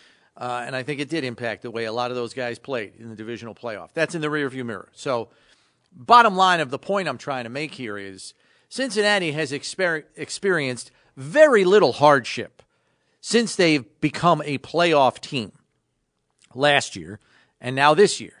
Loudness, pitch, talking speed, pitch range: -21 LUFS, 140 Hz, 180 wpm, 120-175 Hz